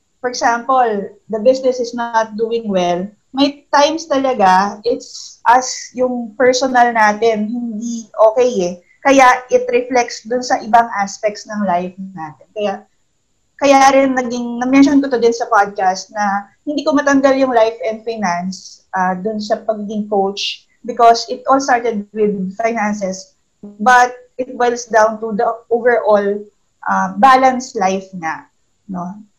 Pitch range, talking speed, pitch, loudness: 205-250 Hz, 145 wpm, 230 Hz, -15 LUFS